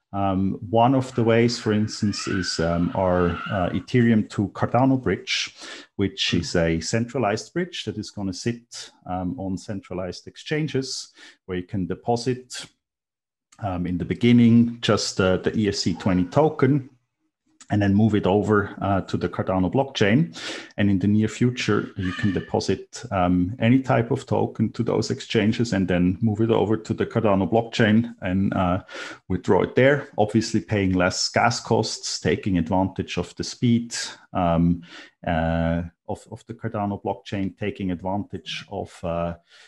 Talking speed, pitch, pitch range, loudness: 155 wpm, 105 Hz, 95-120 Hz, -23 LUFS